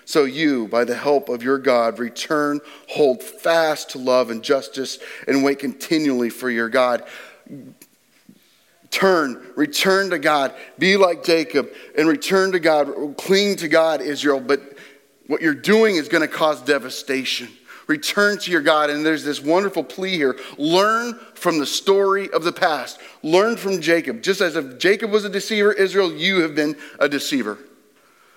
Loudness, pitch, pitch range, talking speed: -19 LUFS, 160 Hz, 140-195 Hz, 165 wpm